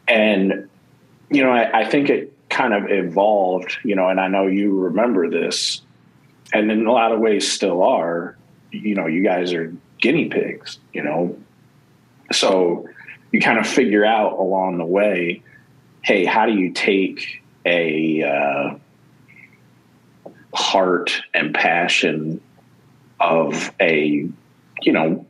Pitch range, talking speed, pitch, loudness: 80-100 Hz, 140 wpm, 90 Hz, -18 LUFS